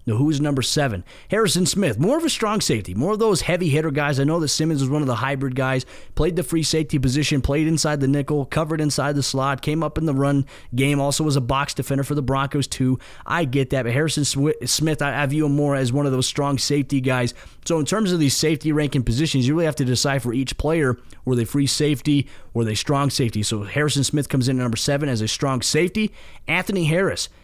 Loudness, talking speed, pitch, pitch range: -21 LUFS, 240 wpm, 145 Hz, 130-155 Hz